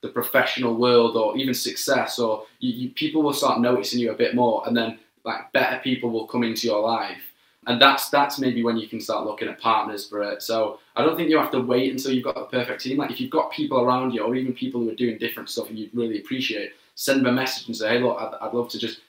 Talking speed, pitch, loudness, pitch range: 275 wpm, 125 Hz, -23 LUFS, 115-135 Hz